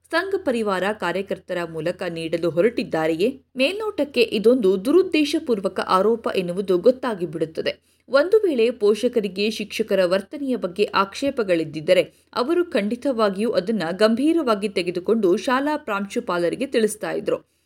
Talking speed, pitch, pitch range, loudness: 95 wpm, 215 Hz, 185-260 Hz, -22 LUFS